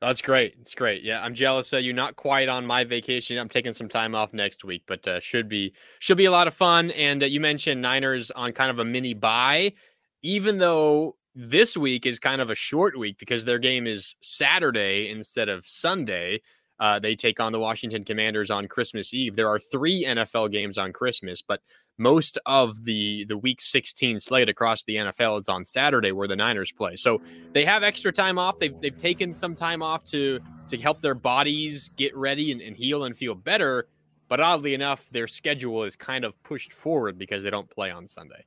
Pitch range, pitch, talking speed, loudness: 110-145 Hz, 125 Hz, 210 wpm, -24 LUFS